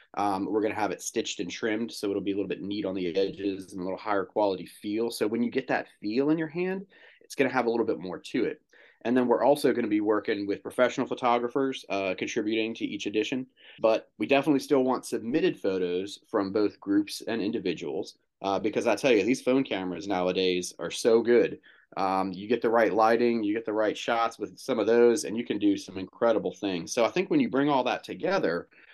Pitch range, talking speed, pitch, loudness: 100-130 Hz, 240 wpm, 115 Hz, -28 LUFS